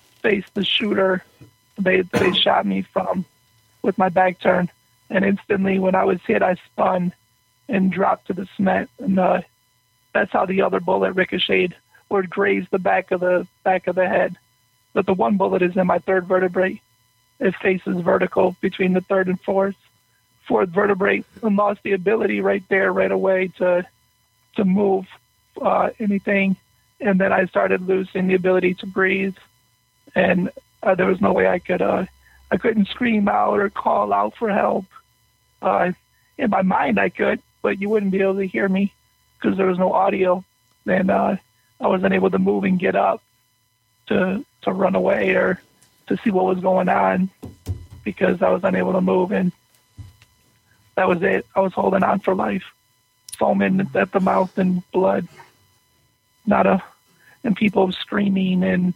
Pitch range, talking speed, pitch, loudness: 125-195 Hz, 175 wpm, 185 Hz, -20 LUFS